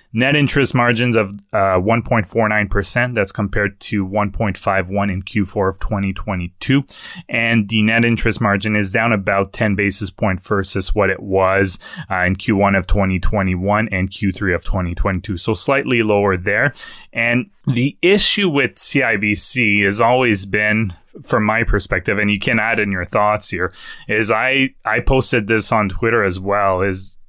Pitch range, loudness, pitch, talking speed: 95-115 Hz, -17 LUFS, 105 Hz, 155 wpm